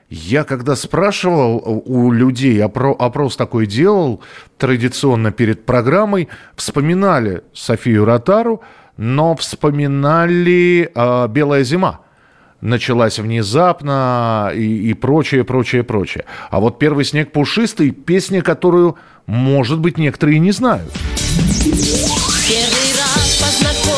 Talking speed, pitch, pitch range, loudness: 100 wpm, 135 Hz, 120-170 Hz, -14 LUFS